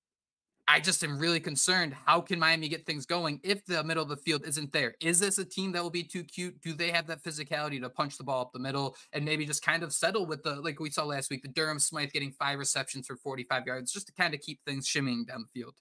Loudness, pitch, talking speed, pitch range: -31 LUFS, 155 Hz, 275 wpm, 140-170 Hz